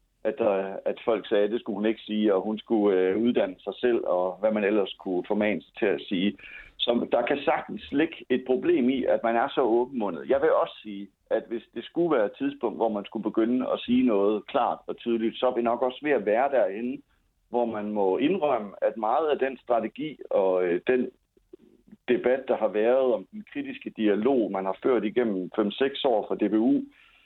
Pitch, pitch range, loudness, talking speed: 115 Hz, 105-135 Hz, -26 LUFS, 215 wpm